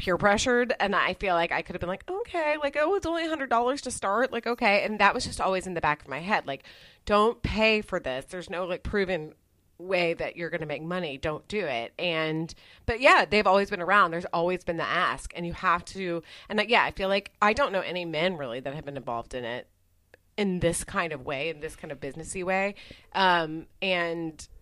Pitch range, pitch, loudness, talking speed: 160-205 Hz, 180 Hz, -27 LUFS, 245 wpm